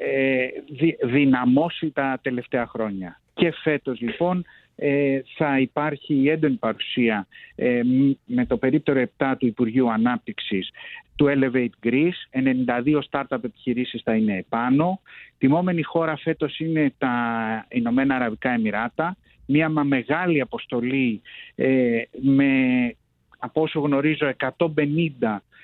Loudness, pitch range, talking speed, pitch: -23 LUFS, 125-155 Hz, 110 wpm, 135 Hz